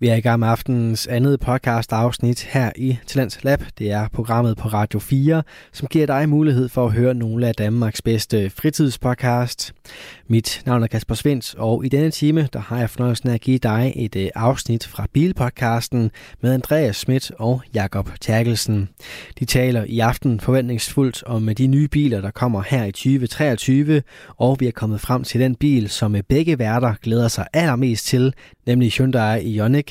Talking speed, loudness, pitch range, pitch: 185 wpm, -19 LUFS, 115-130 Hz, 120 Hz